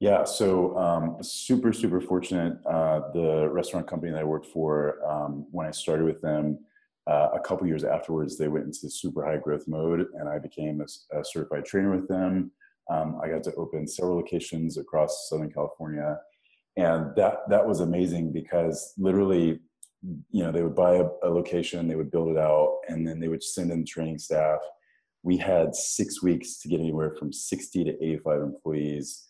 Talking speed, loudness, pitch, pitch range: 190 wpm, -27 LUFS, 80 Hz, 75-90 Hz